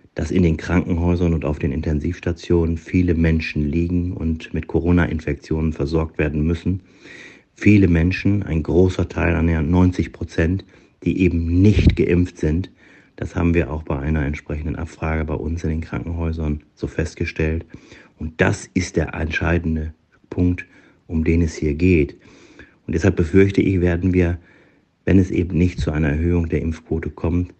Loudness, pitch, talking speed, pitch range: -20 LUFS, 85 Hz, 155 wpm, 80-90 Hz